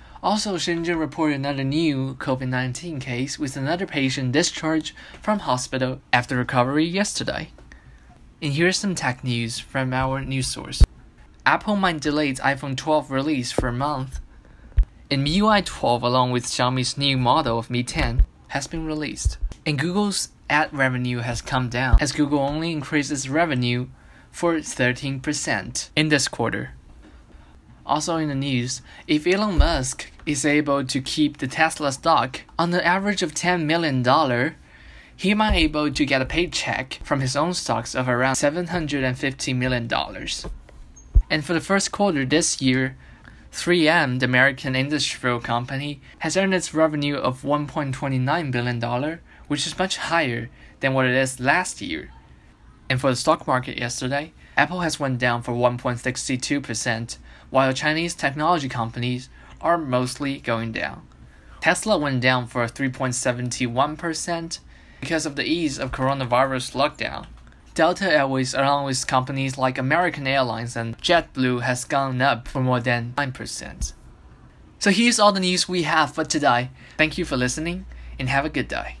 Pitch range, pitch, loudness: 125-155 Hz, 135 Hz, -22 LUFS